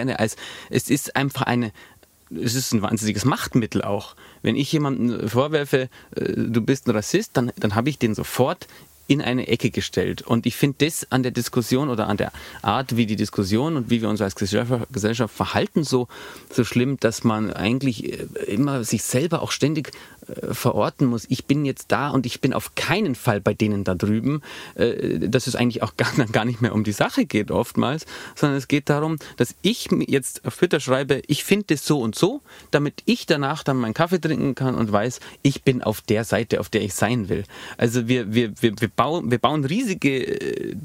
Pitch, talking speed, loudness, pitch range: 125 Hz, 200 wpm, -22 LUFS, 110-140 Hz